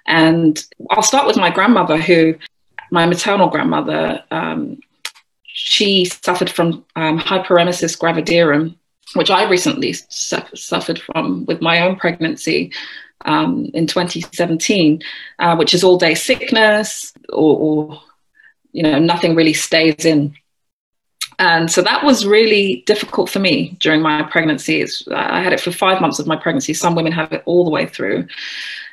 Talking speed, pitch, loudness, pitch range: 150 wpm, 170 Hz, -15 LUFS, 160-185 Hz